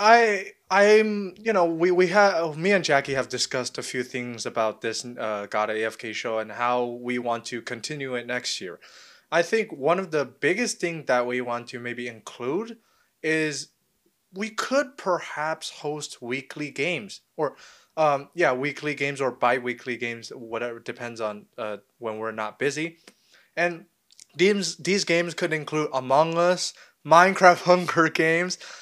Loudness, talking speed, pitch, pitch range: -25 LUFS, 165 wpm, 150 Hz, 120-180 Hz